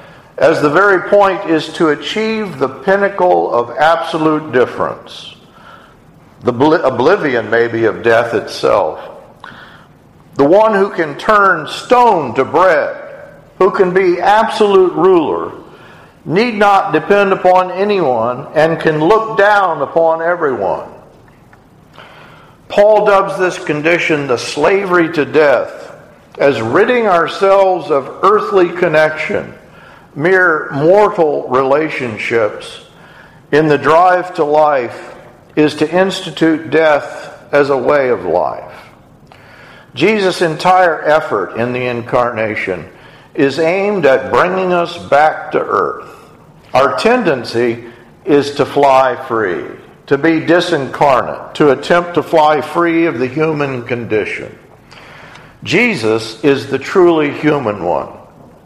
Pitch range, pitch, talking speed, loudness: 145-195 Hz, 165 Hz, 115 wpm, -12 LUFS